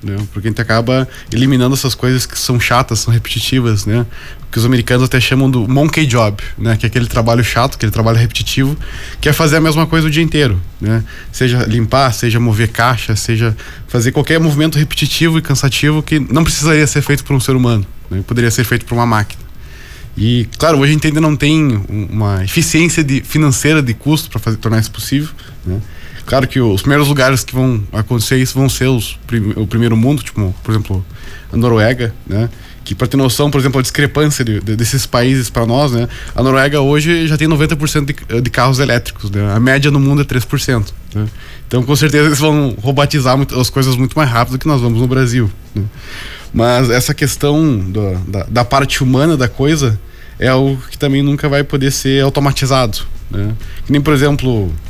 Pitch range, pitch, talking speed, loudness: 115-140 Hz, 125 Hz, 205 wpm, -13 LUFS